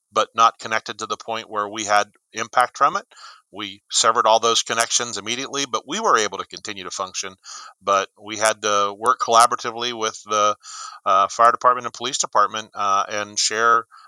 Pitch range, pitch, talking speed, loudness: 105-115 Hz, 110 Hz, 185 wpm, -20 LUFS